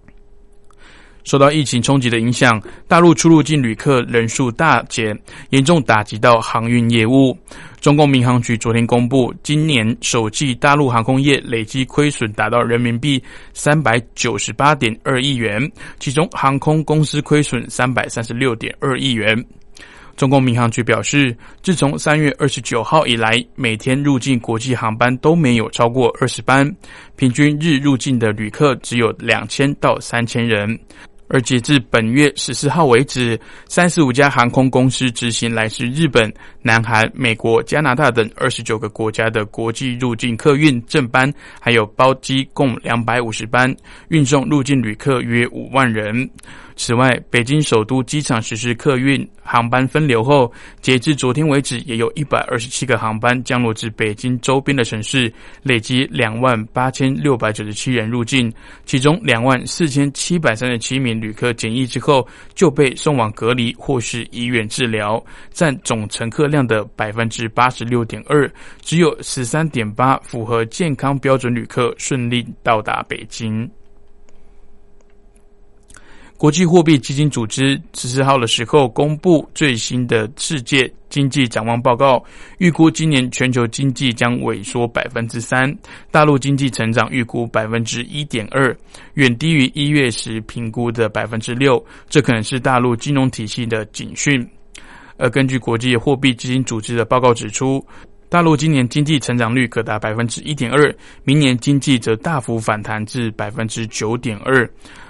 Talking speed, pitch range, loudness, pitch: 255 characters per minute, 115-140 Hz, -16 LUFS, 125 Hz